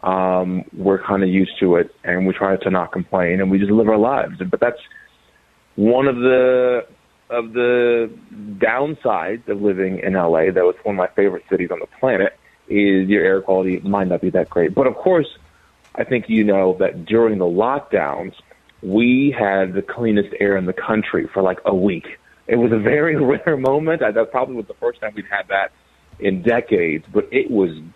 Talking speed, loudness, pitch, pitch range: 205 wpm, -18 LUFS, 100 Hz, 95-120 Hz